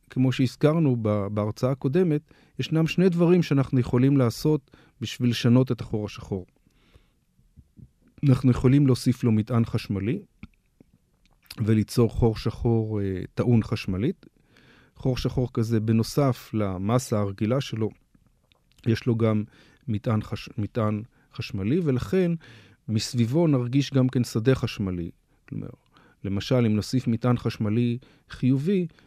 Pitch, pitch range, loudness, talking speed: 120 Hz, 110-135 Hz, -25 LUFS, 110 wpm